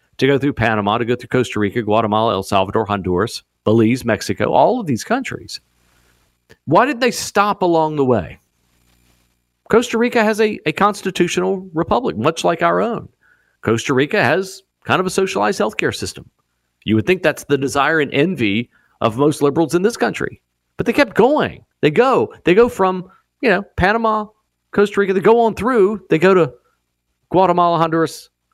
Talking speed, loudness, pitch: 175 wpm, -17 LUFS, 150 Hz